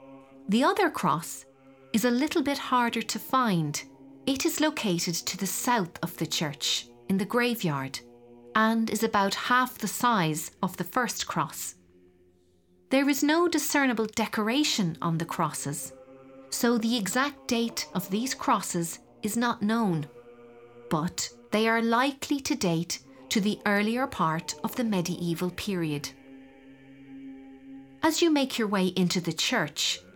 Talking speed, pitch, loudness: 145 wpm, 185 Hz, -27 LUFS